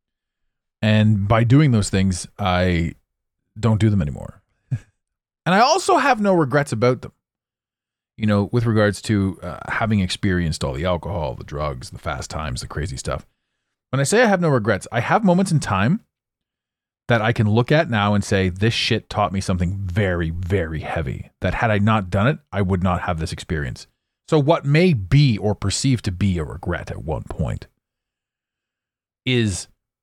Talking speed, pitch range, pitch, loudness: 180 wpm, 95-125 Hz, 105 Hz, -20 LUFS